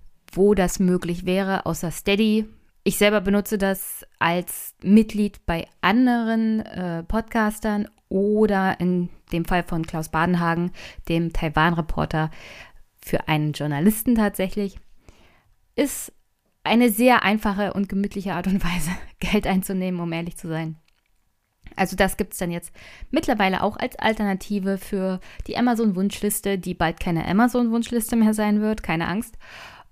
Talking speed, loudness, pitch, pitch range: 130 wpm, -23 LUFS, 195 Hz, 170-215 Hz